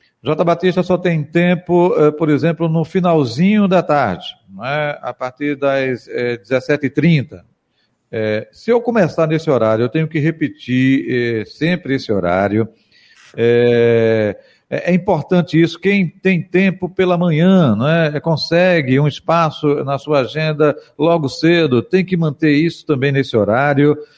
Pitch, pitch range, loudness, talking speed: 150 Hz, 135-170 Hz, -15 LUFS, 140 wpm